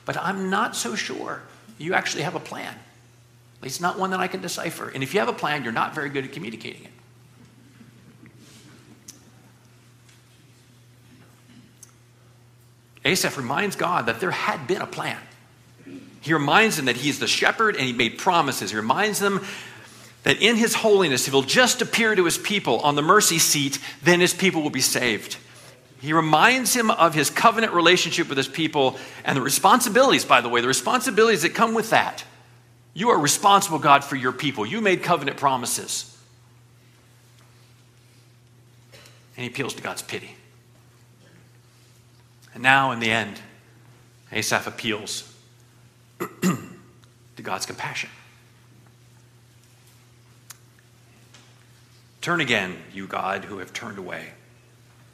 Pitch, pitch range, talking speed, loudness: 125 Hz, 120-165 Hz, 145 wpm, -21 LUFS